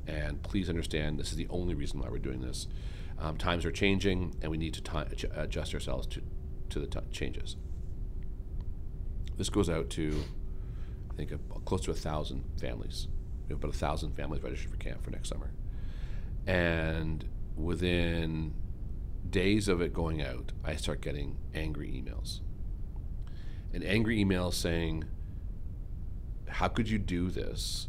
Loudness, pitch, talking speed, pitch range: -35 LUFS, 85 Hz, 155 wpm, 75-95 Hz